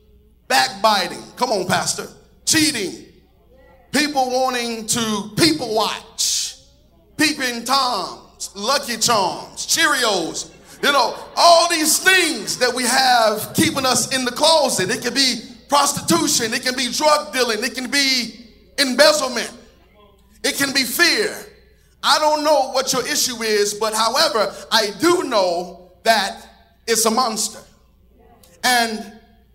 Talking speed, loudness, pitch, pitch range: 125 wpm, -17 LUFS, 255 Hz, 225-290 Hz